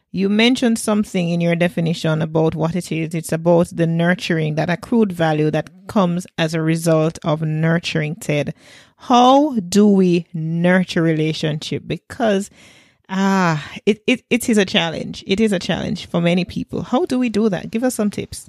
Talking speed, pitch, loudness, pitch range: 175 wpm, 175 Hz, -18 LUFS, 160-210 Hz